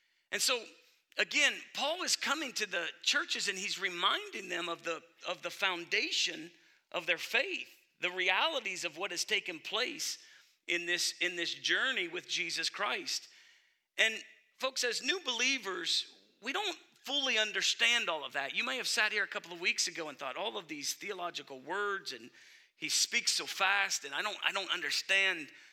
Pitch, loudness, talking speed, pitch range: 210 Hz, -32 LUFS, 175 wpm, 180-285 Hz